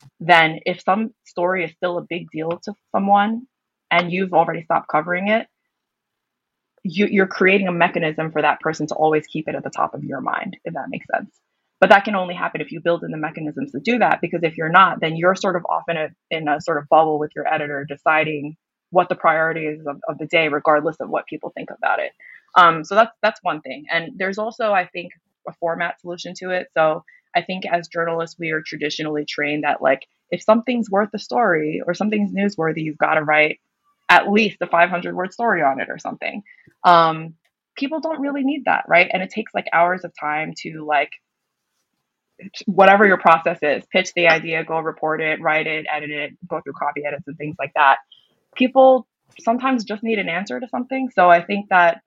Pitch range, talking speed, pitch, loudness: 155-200 Hz, 215 wpm, 170 Hz, -19 LUFS